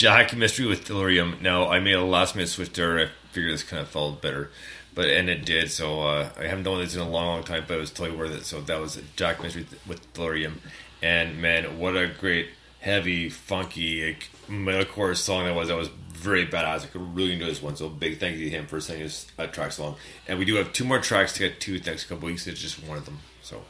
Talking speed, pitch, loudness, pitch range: 265 wpm, 85 Hz, -26 LUFS, 80-90 Hz